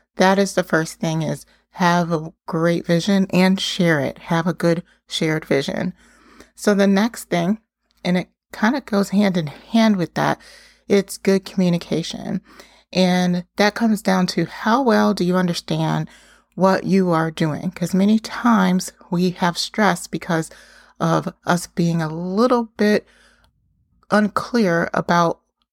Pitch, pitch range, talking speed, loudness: 185 Hz, 170-210 Hz, 150 wpm, -20 LUFS